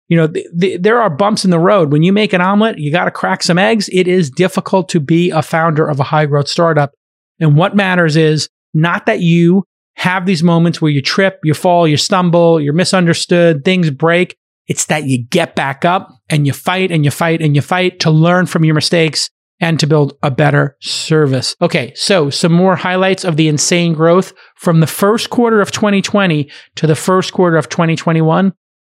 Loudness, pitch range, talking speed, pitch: -12 LUFS, 155-185 Hz, 210 wpm, 170 Hz